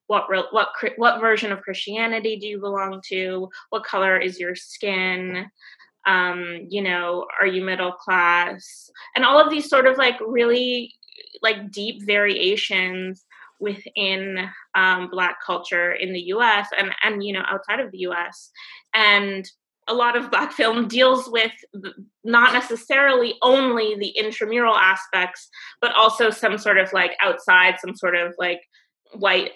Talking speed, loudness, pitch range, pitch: 150 wpm, -20 LUFS, 185-230 Hz, 205 Hz